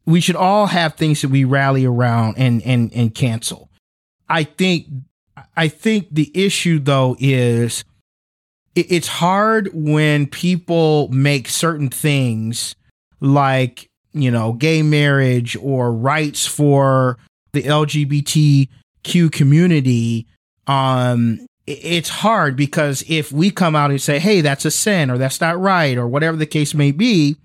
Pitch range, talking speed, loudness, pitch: 125-160 Hz, 140 wpm, -16 LUFS, 145 Hz